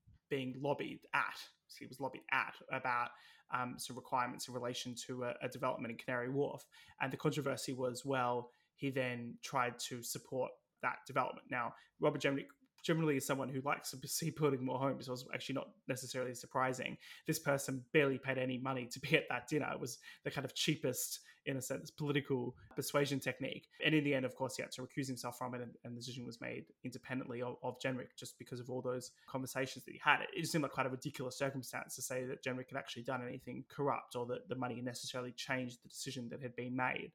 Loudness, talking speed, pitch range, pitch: -40 LUFS, 215 wpm, 125-140 Hz, 130 Hz